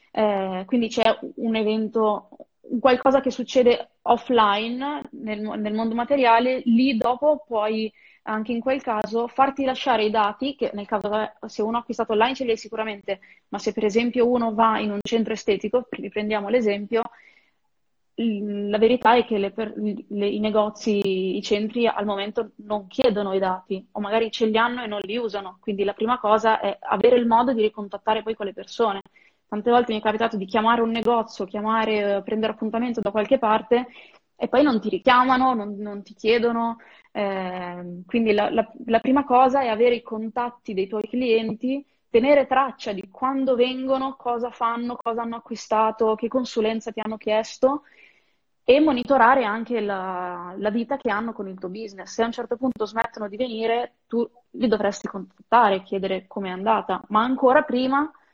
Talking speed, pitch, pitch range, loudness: 175 wpm, 225 Hz, 210-245 Hz, -23 LUFS